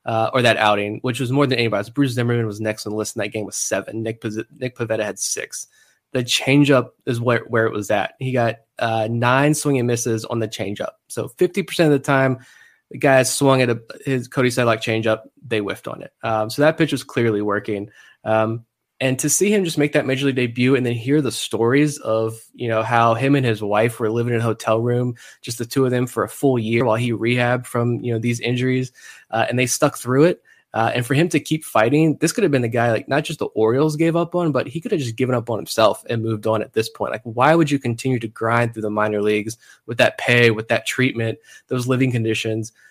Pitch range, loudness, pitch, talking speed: 110-135 Hz, -20 LUFS, 120 Hz, 250 wpm